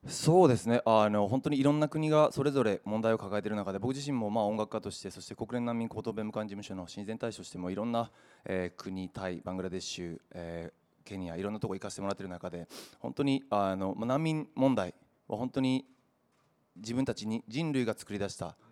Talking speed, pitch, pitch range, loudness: 425 characters per minute, 110 Hz, 95-130 Hz, -32 LUFS